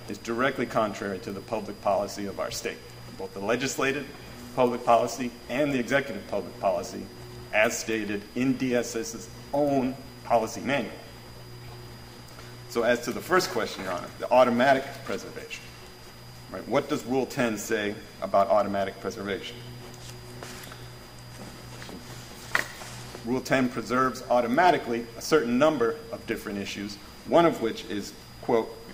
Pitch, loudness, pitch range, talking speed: 120 Hz, -27 LUFS, 110-130 Hz, 130 wpm